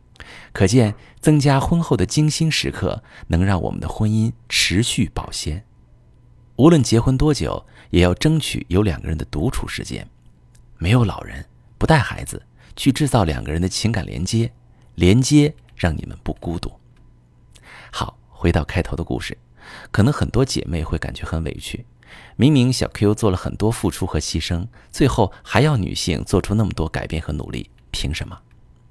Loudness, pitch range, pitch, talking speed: -20 LUFS, 85-125 Hz, 105 Hz, 250 characters per minute